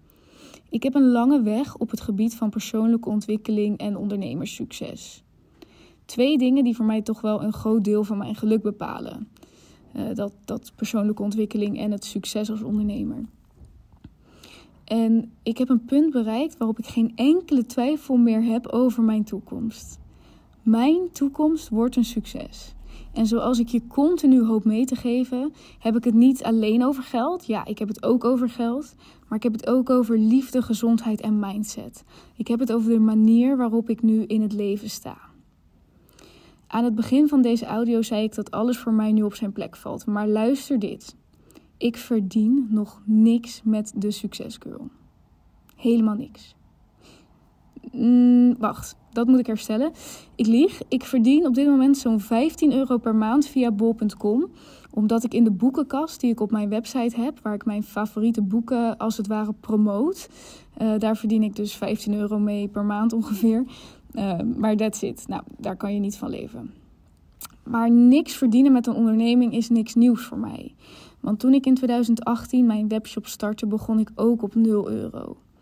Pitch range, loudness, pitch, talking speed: 215-250 Hz, -22 LUFS, 230 Hz, 175 wpm